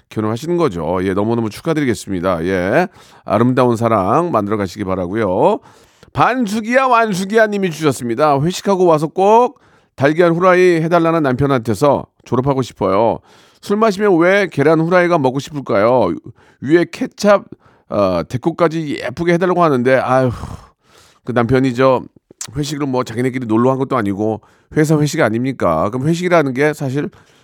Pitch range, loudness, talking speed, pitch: 120-175 Hz, -15 LUFS, 345 characters per minute, 140 Hz